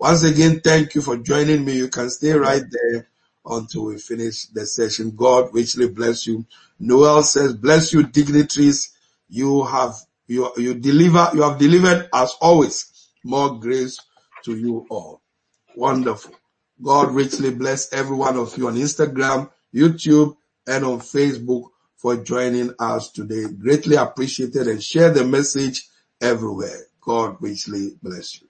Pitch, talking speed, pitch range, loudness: 130 Hz, 145 wpm, 120-150 Hz, -18 LUFS